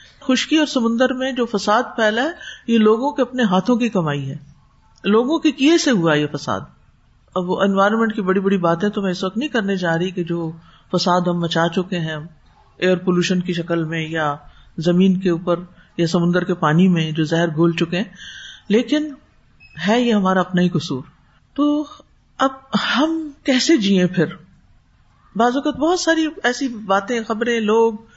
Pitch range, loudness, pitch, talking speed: 170-245 Hz, -19 LUFS, 195 Hz, 185 wpm